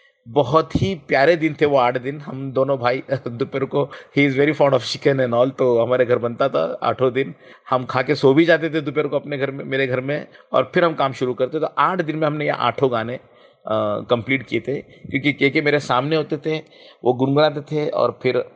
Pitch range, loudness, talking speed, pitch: 130-150 Hz, -20 LUFS, 235 wpm, 140 Hz